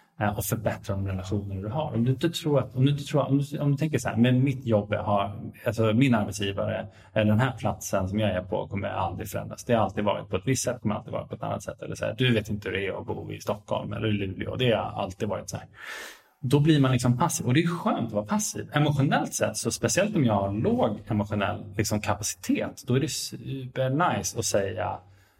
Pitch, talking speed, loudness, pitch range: 115 Hz, 220 wpm, -27 LUFS, 105-135 Hz